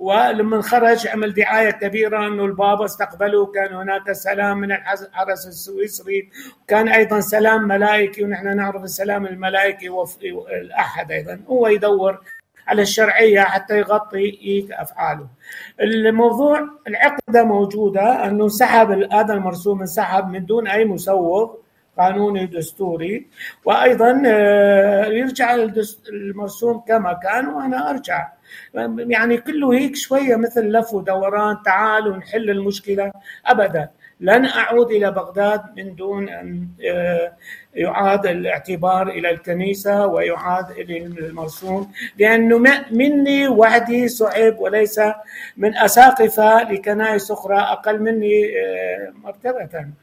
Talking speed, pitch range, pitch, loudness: 105 wpm, 195-225 Hz, 205 Hz, -17 LUFS